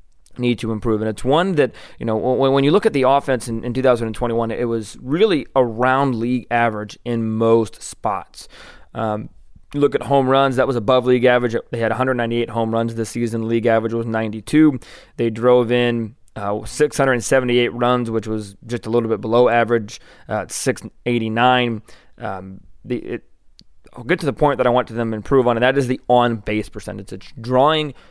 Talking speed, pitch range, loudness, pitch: 190 wpm, 115-130 Hz, -19 LUFS, 120 Hz